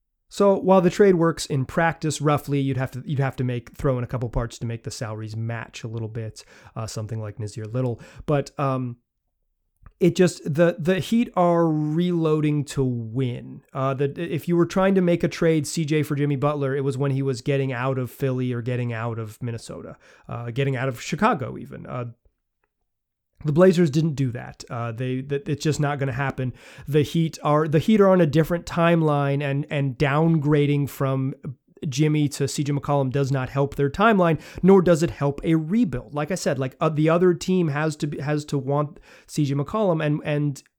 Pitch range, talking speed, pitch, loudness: 130-160 Hz, 205 wpm, 145 Hz, -23 LUFS